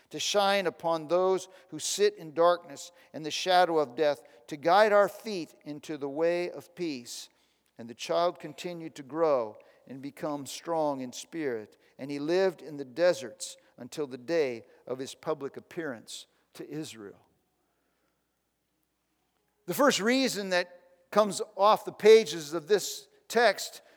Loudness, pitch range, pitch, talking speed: -28 LUFS, 145-190 Hz, 165 Hz, 150 wpm